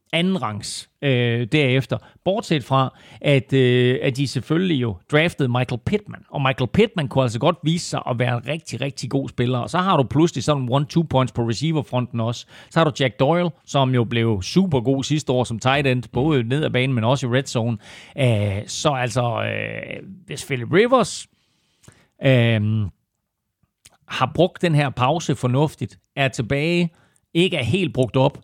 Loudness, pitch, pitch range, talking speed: -21 LUFS, 135 Hz, 125-150 Hz, 185 wpm